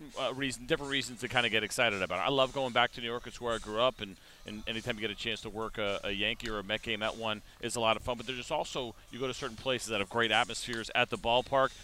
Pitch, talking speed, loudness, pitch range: 115 Hz, 315 wpm, -32 LUFS, 110-125 Hz